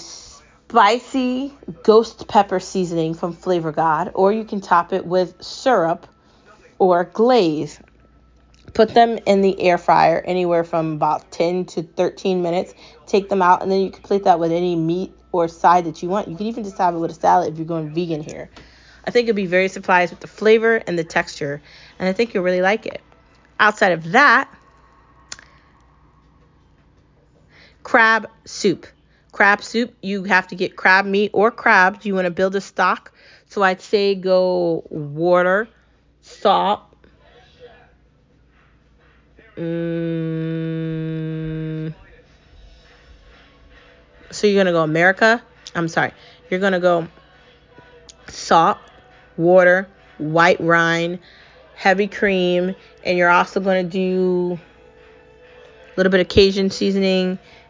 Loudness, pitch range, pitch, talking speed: -18 LUFS, 165-200 Hz, 185 Hz, 140 wpm